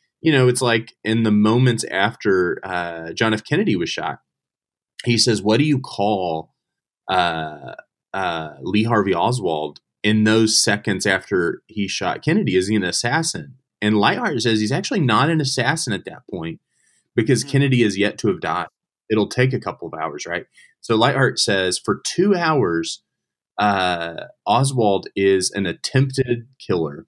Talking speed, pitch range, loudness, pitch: 160 wpm, 100-130 Hz, -19 LUFS, 110 Hz